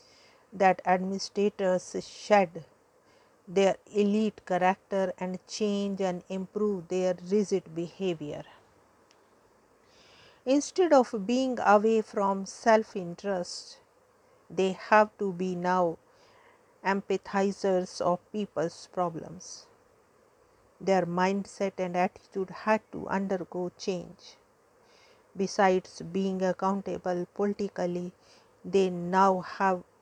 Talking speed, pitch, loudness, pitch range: 90 wpm, 195 Hz, -29 LUFS, 185-235 Hz